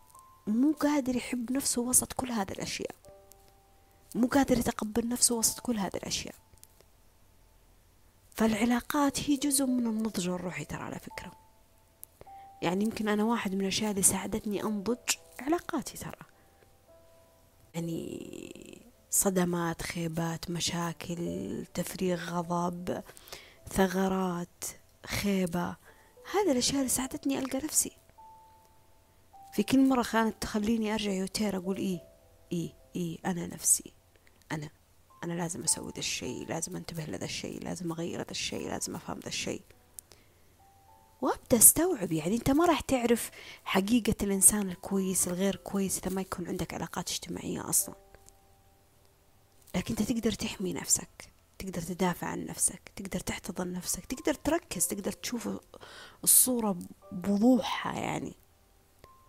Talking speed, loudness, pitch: 120 wpm, -30 LUFS, 190 Hz